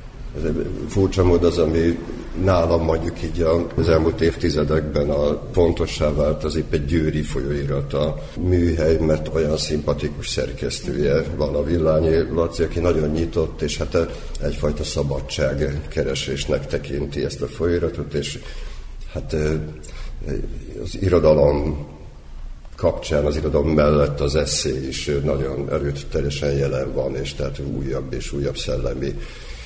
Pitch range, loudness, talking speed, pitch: 70-80 Hz, -21 LUFS, 125 wpm, 75 Hz